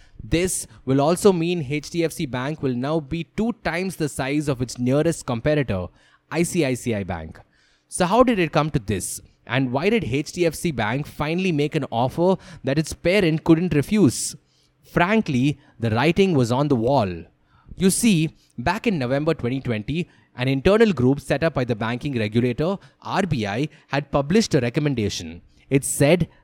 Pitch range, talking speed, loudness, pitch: 125-170 Hz, 155 wpm, -22 LUFS, 145 Hz